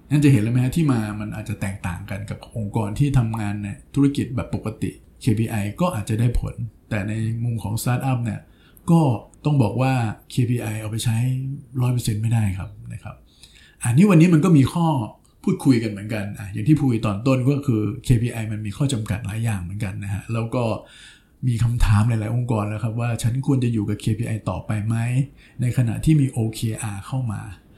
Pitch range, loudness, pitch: 105-130 Hz, -22 LUFS, 115 Hz